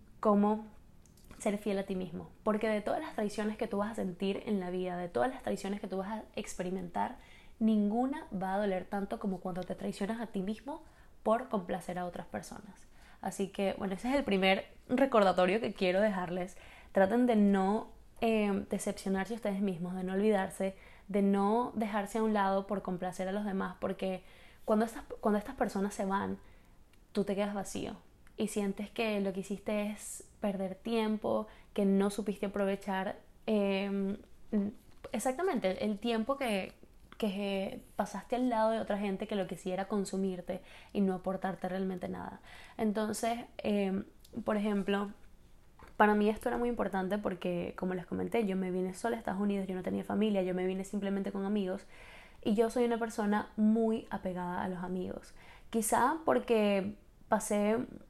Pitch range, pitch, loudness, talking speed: 190-220 Hz, 205 Hz, -34 LUFS, 175 wpm